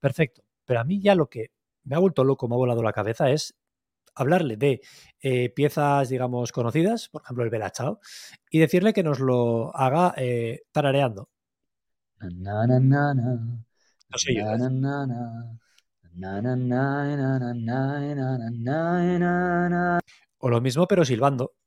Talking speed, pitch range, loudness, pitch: 120 wpm, 120-150 Hz, -24 LUFS, 130 Hz